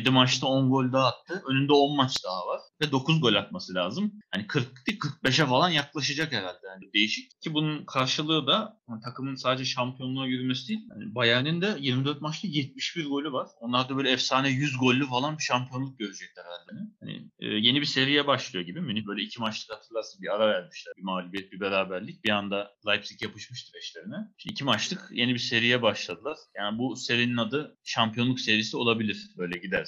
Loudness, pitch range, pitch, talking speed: -27 LUFS, 115-150 Hz, 130 Hz, 185 wpm